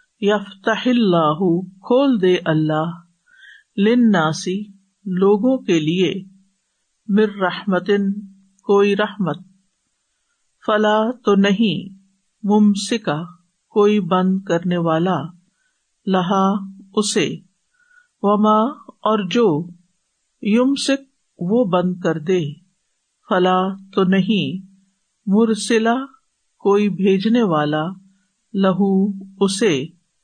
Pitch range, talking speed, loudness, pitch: 185-215 Hz, 80 wpm, -18 LUFS, 195 Hz